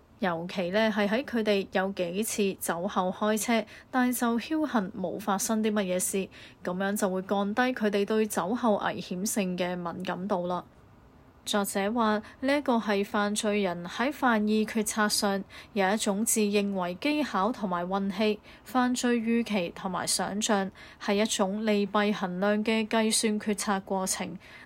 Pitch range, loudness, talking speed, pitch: 195-220 Hz, -28 LUFS, 230 characters per minute, 210 Hz